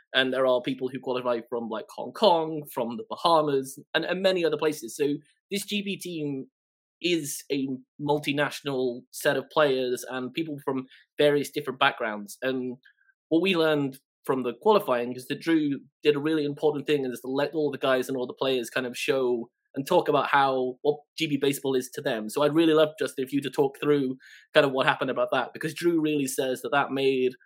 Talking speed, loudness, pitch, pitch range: 210 wpm, -26 LUFS, 140 Hz, 130-155 Hz